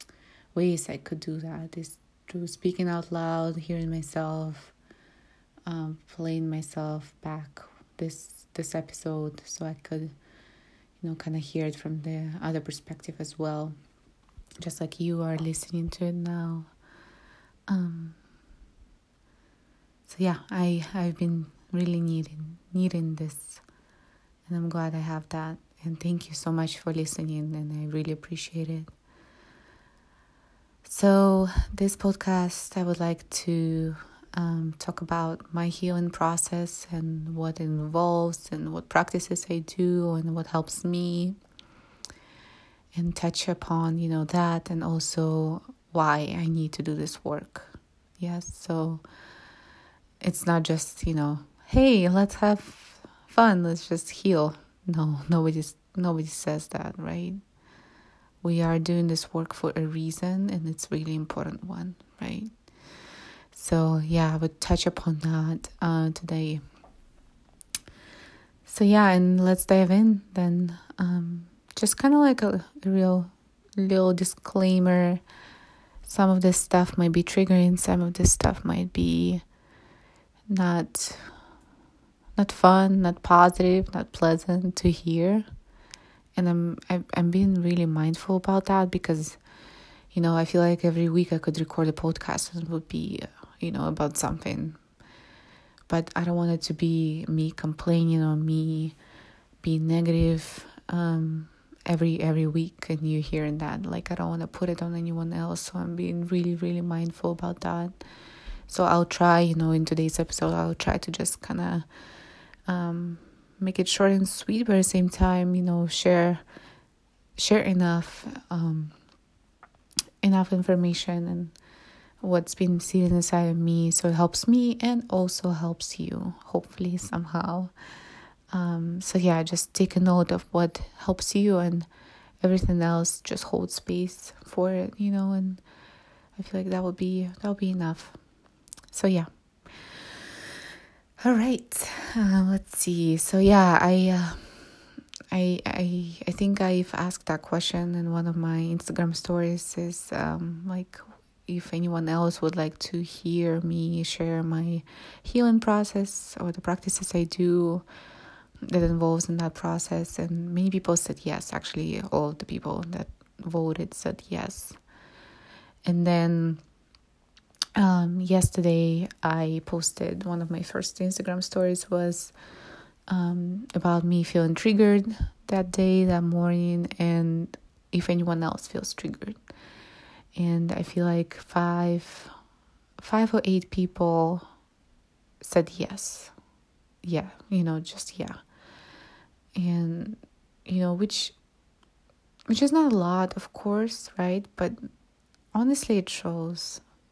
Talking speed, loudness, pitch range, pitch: 140 wpm, -26 LUFS, 160-185 Hz, 170 Hz